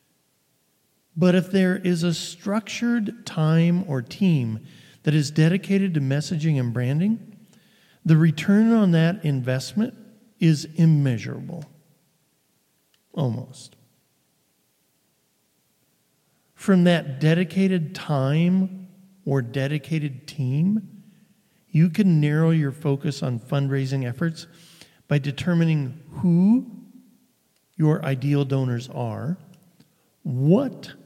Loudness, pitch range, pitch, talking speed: -22 LUFS, 140-190 Hz, 165 Hz, 90 wpm